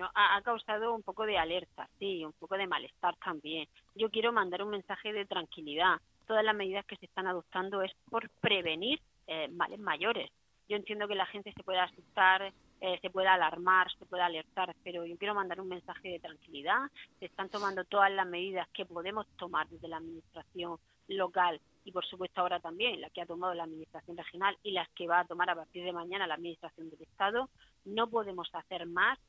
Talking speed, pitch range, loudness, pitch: 205 wpm, 170-200 Hz, -34 LUFS, 185 Hz